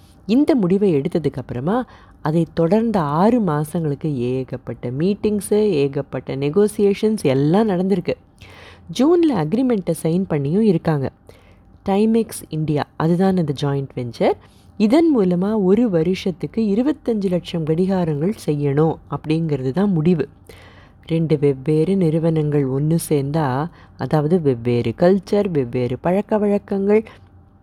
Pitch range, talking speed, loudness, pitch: 140-200 Hz, 100 wpm, -19 LUFS, 165 Hz